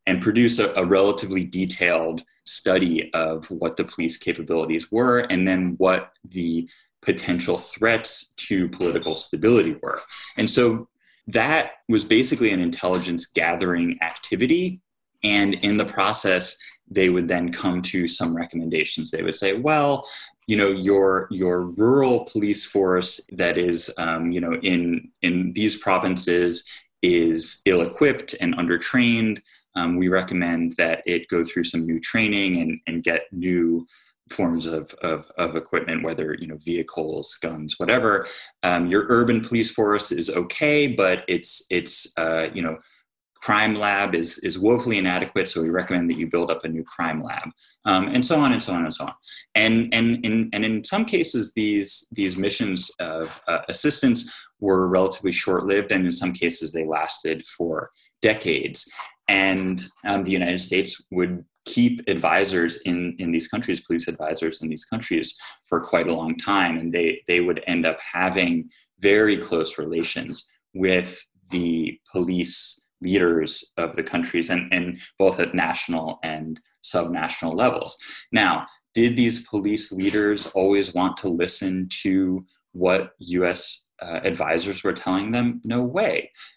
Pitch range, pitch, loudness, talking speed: 85-105 Hz, 90 Hz, -22 LUFS, 155 wpm